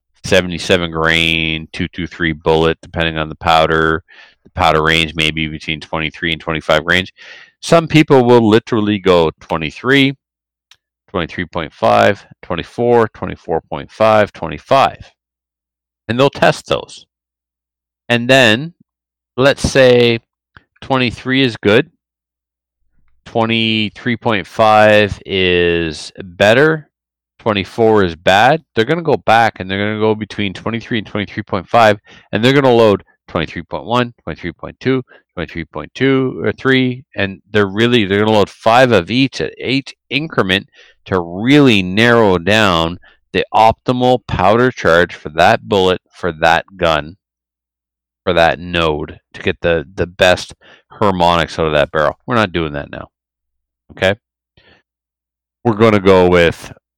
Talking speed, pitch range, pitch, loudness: 125 wpm, 80-115 Hz, 95 Hz, -14 LUFS